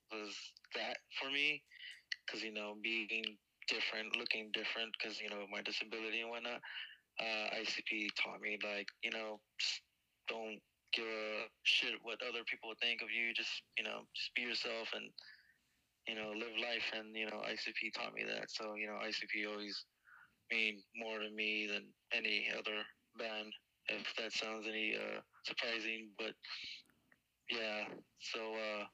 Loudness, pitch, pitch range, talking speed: -41 LUFS, 110 Hz, 105-115 Hz, 160 wpm